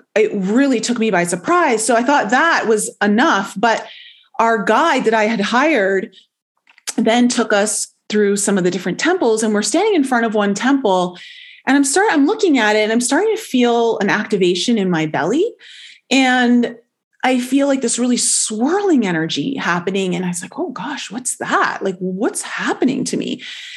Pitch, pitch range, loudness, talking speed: 235 Hz, 205-285 Hz, -16 LUFS, 190 wpm